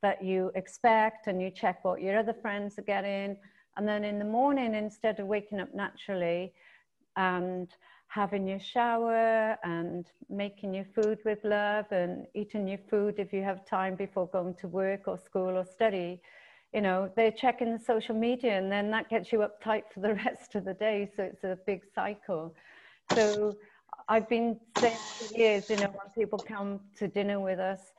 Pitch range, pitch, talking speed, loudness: 190-220 Hz, 205 Hz, 185 wpm, -31 LUFS